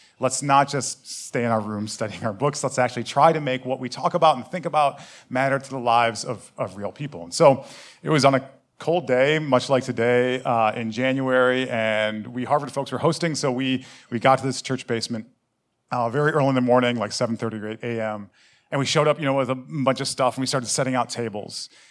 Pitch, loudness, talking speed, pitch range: 130 Hz, -23 LUFS, 235 wpm, 120-135 Hz